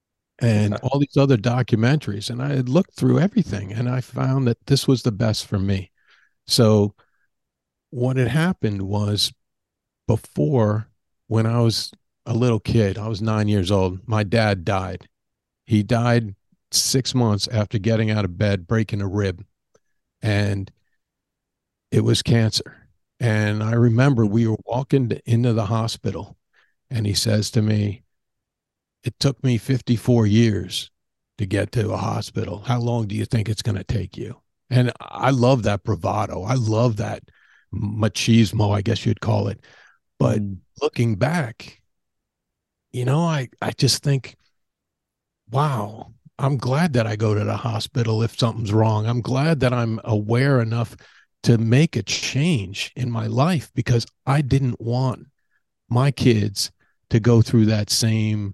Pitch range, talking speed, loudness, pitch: 105-125 Hz, 155 wpm, -21 LUFS, 115 Hz